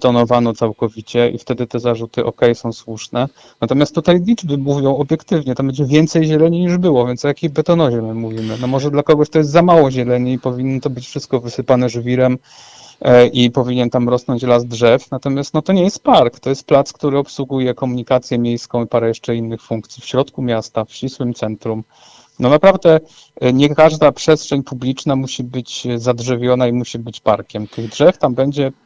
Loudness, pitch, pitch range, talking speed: -15 LUFS, 130 Hz, 120-145 Hz, 185 wpm